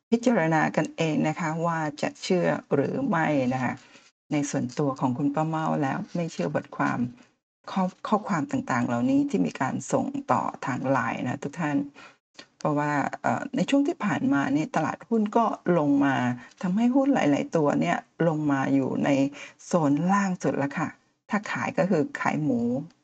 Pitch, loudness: 175 Hz, -26 LUFS